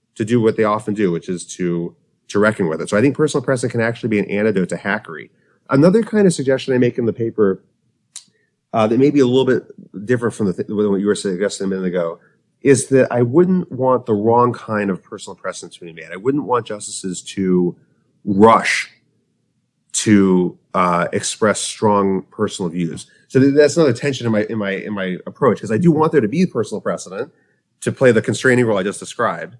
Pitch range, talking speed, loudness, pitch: 100-130 Hz, 215 wpm, -17 LUFS, 115 Hz